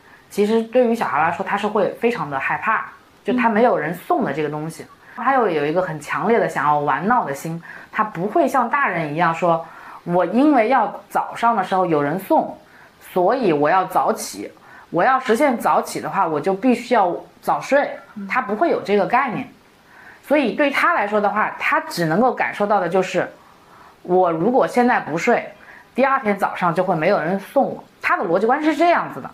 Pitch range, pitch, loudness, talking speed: 180-255 Hz, 210 Hz, -19 LUFS, 285 characters per minute